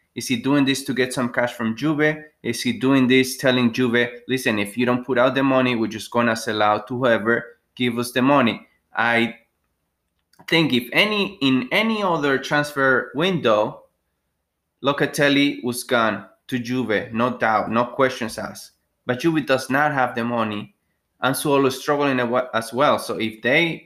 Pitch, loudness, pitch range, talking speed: 125 Hz, -20 LUFS, 115-135 Hz, 180 wpm